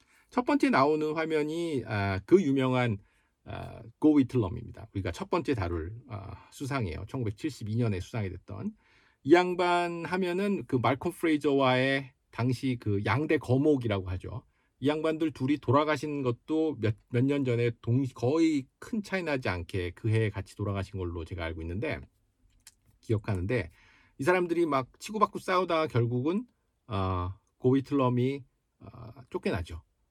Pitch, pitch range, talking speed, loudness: 125 Hz, 100-150 Hz, 280 characters per minute, -29 LUFS